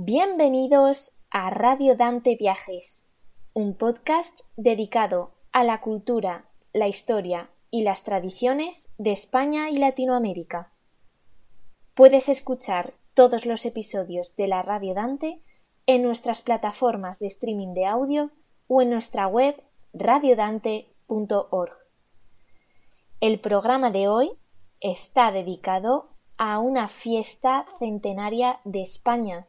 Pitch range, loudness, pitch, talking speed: 200-255 Hz, -23 LUFS, 230 Hz, 110 wpm